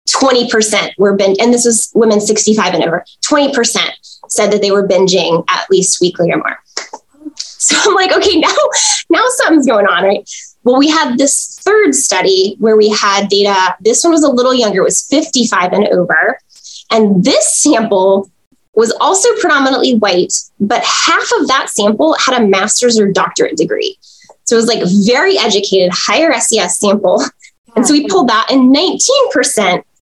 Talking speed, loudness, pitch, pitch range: 170 wpm, -10 LUFS, 230 Hz, 200-300 Hz